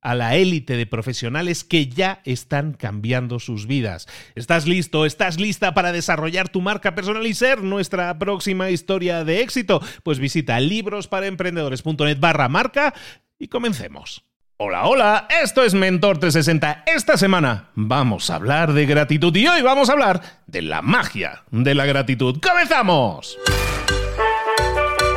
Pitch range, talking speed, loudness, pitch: 140-200 Hz, 140 wpm, -19 LUFS, 175 Hz